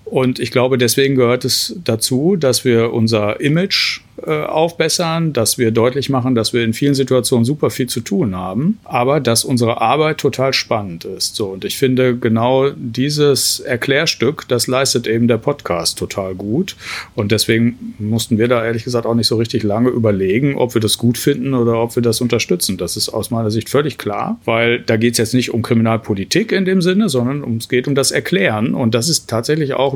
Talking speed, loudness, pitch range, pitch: 200 wpm, -16 LUFS, 115-135 Hz, 120 Hz